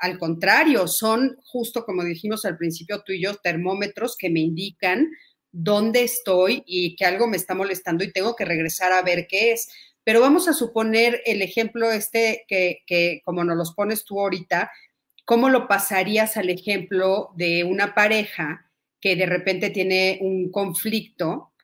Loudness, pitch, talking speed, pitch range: -21 LUFS, 195 Hz, 165 wpm, 180-220 Hz